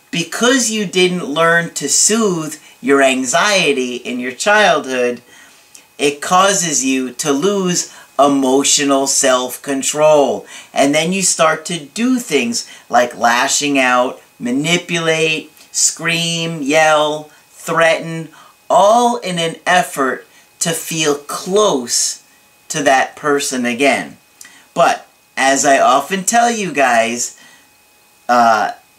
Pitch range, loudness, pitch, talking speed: 135-180 Hz, -14 LUFS, 155 Hz, 105 wpm